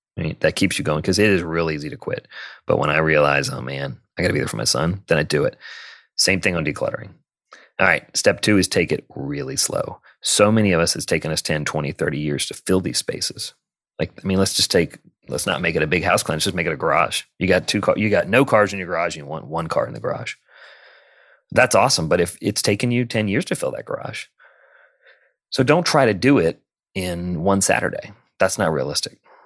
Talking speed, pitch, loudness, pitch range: 250 wpm, 95 Hz, -20 LUFS, 80-110 Hz